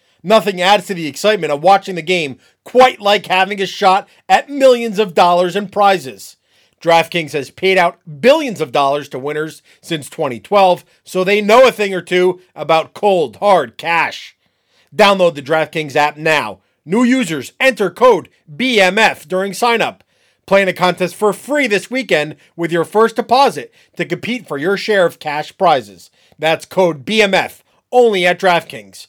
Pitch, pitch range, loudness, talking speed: 185 Hz, 165-210 Hz, -14 LUFS, 165 wpm